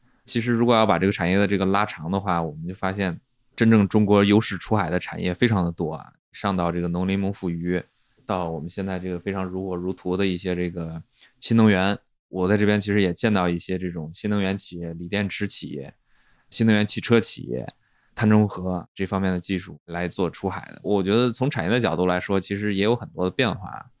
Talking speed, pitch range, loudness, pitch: 330 characters per minute, 90-105 Hz, -23 LUFS, 95 Hz